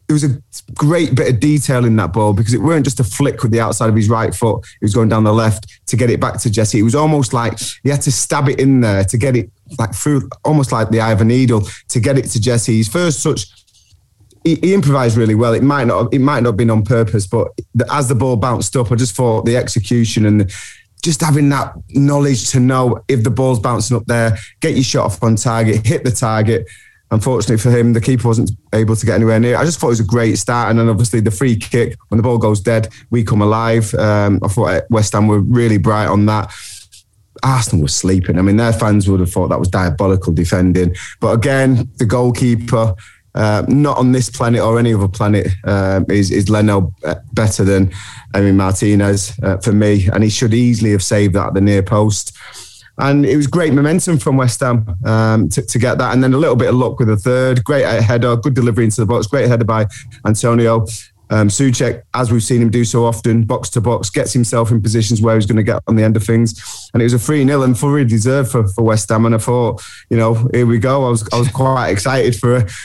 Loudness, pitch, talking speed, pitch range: -14 LUFS, 115 Hz, 245 wpm, 110-125 Hz